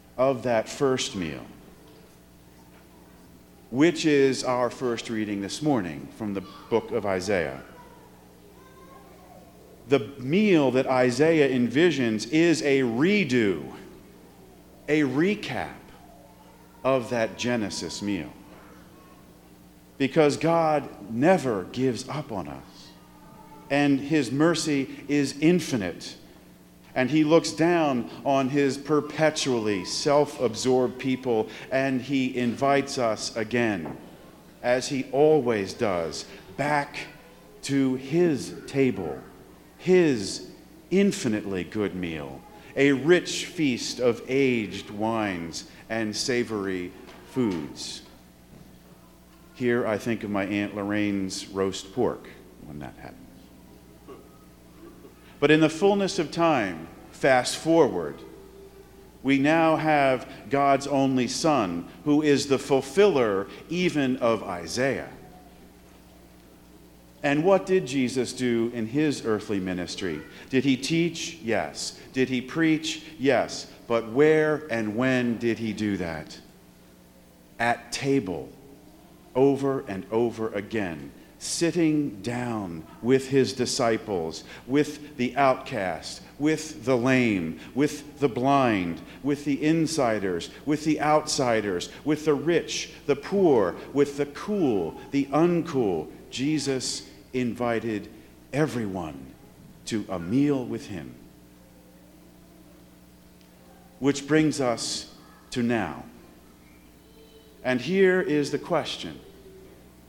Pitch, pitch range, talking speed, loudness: 125 Hz, 95-145 Hz, 105 wpm, -25 LUFS